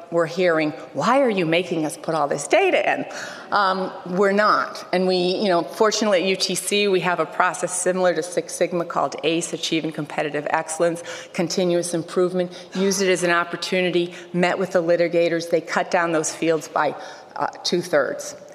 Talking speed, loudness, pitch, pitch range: 180 wpm, -21 LUFS, 175 Hz, 170-185 Hz